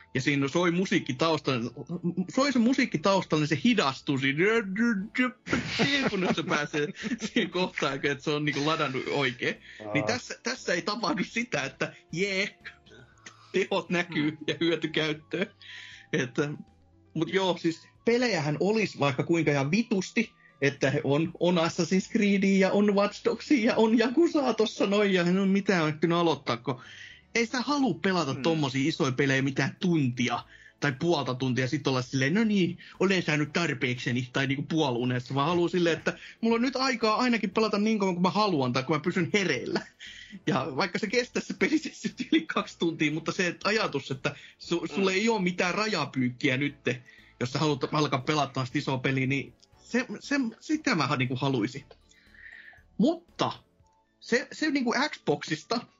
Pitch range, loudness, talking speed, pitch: 145-215 Hz, -27 LUFS, 160 wpm, 170 Hz